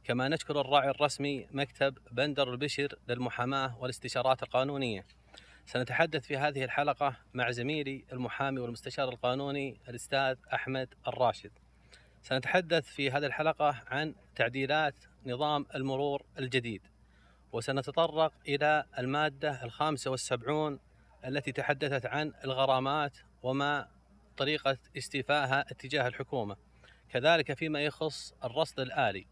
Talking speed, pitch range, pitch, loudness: 100 wpm, 130-150 Hz, 135 Hz, -32 LUFS